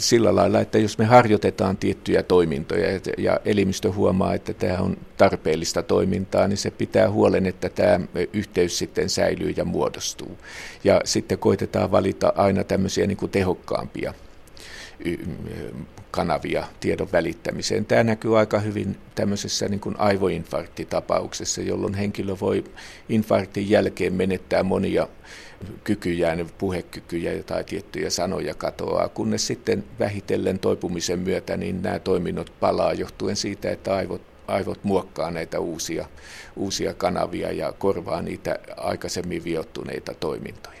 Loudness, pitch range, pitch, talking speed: -23 LUFS, 95-105 Hz, 100 Hz, 125 wpm